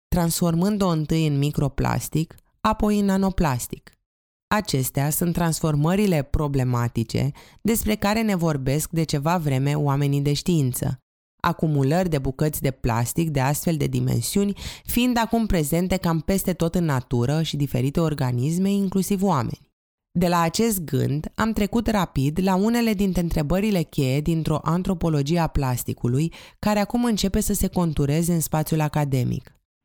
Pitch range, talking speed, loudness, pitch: 140-190 Hz, 135 wpm, -23 LUFS, 160 Hz